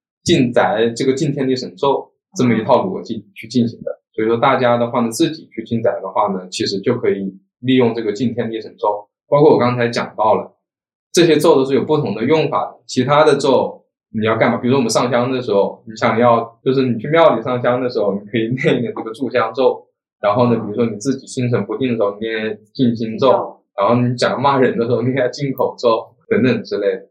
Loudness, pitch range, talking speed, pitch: -17 LUFS, 115-130 Hz, 330 characters per minute, 120 Hz